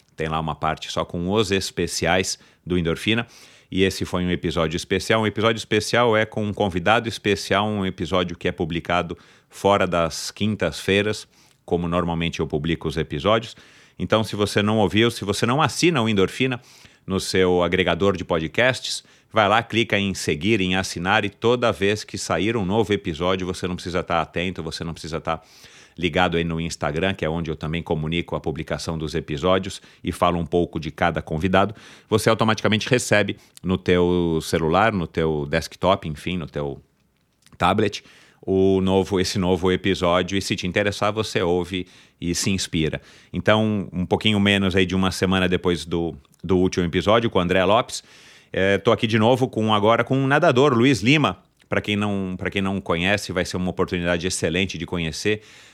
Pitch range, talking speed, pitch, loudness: 85-105 Hz, 180 wpm, 95 Hz, -22 LUFS